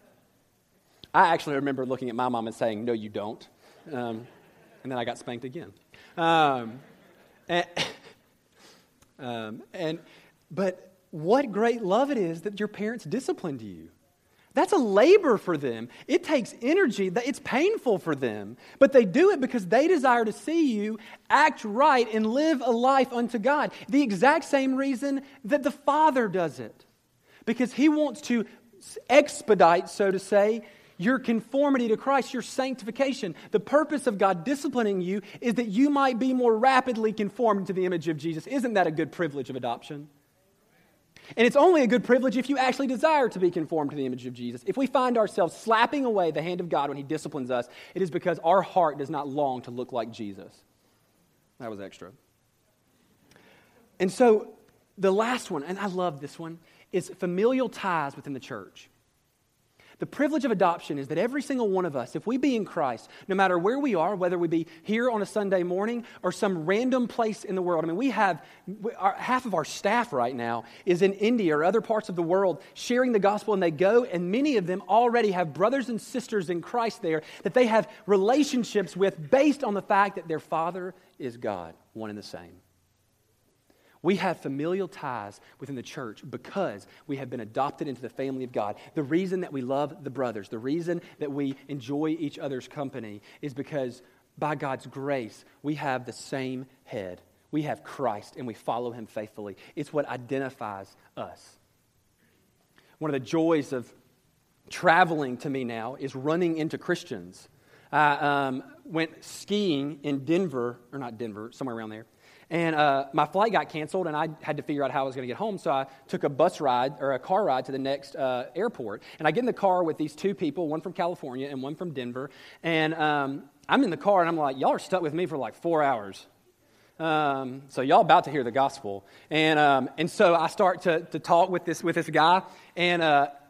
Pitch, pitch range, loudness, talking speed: 175 Hz, 140-220 Hz, -26 LUFS, 200 wpm